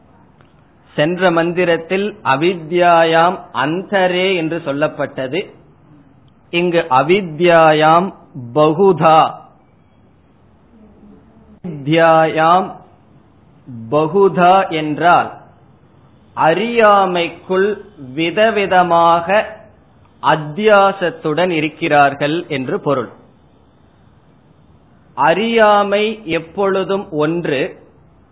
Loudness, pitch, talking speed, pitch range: -14 LUFS, 170 Hz, 45 wpm, 155-190 Hz